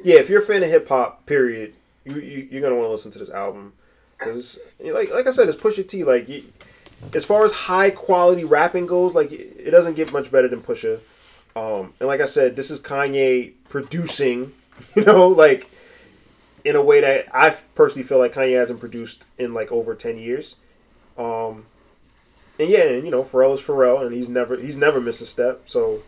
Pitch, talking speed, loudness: 180 Hz, 205 wpm, -18 LUFS